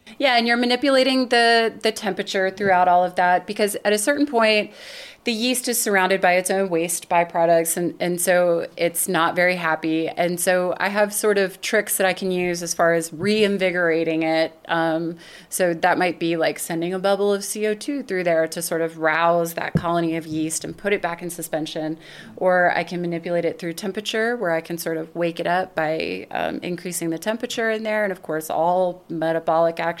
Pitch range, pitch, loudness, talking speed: 170-205 Hz, 180 Hz, -21 LUFS, 205 wpm